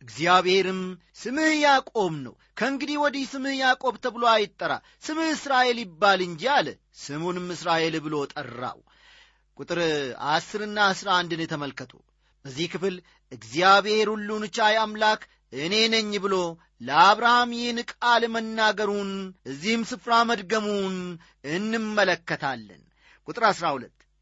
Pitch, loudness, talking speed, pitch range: 205 Hz, -24 LUFS, 105 wpm, 175-235 Hz